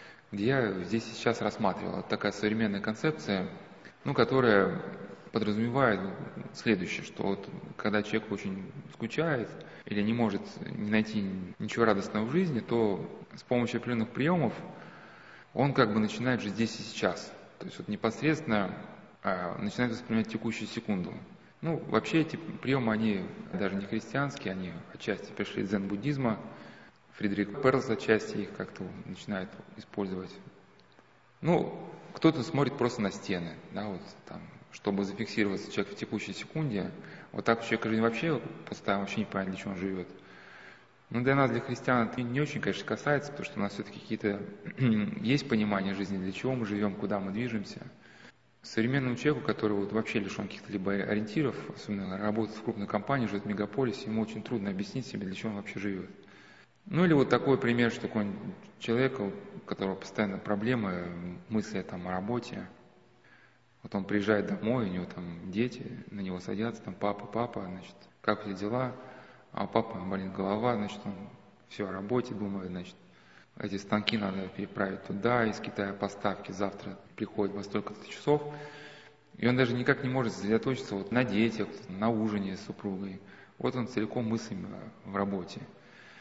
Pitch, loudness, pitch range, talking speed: 110 Hz, -32 LUFS, 100-125 Hz, 160 wpm